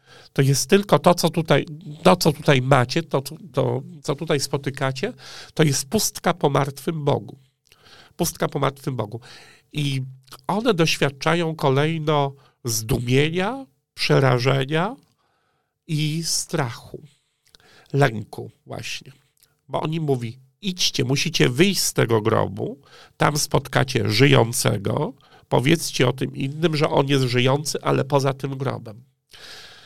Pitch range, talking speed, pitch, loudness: 135-160 Hz, 120 wpm, 145 Hz, -21 LUFS